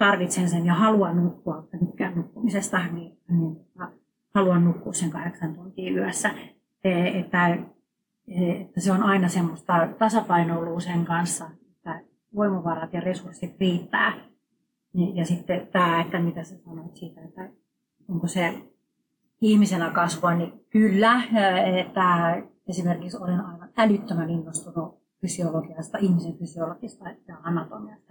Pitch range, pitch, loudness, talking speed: 170-195 Hz, 175 Hz, -24 LUFS, 125 wpm